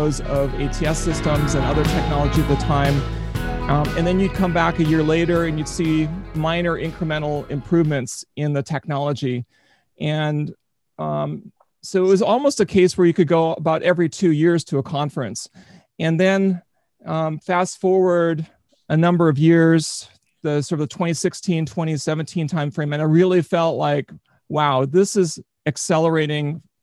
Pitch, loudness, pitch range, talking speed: 160 Hz, -20 LUFS, 145-170 Hz, 160 wpm